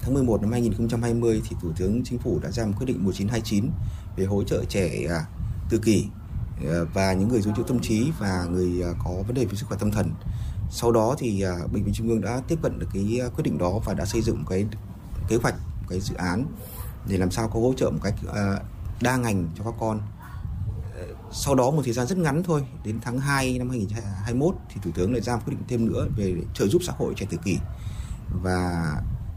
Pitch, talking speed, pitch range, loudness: 105 Hz, 220 wpm, 95-120 Hz, -26 LUFS